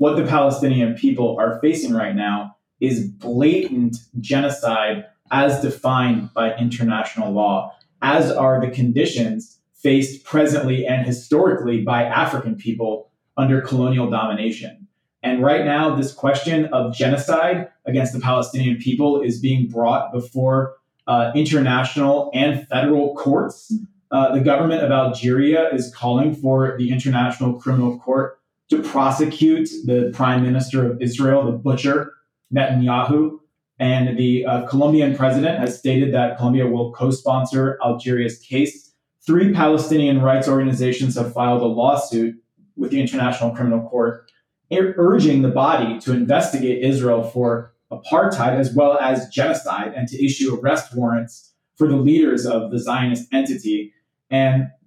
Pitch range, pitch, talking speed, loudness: 120-140 Hz, 130 Hz, 135 wpm, -19 LUFS